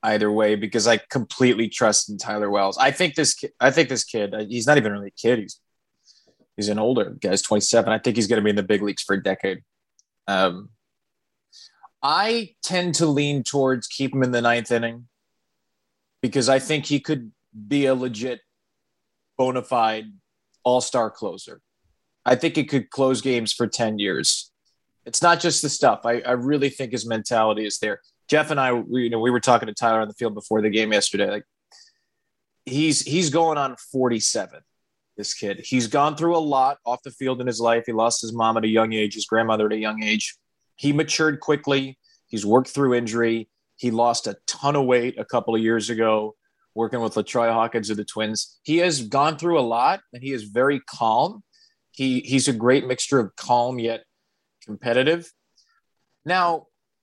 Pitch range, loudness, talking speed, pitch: 110-140 Hz, -22 LUFS, 195 wpm, 125 Hz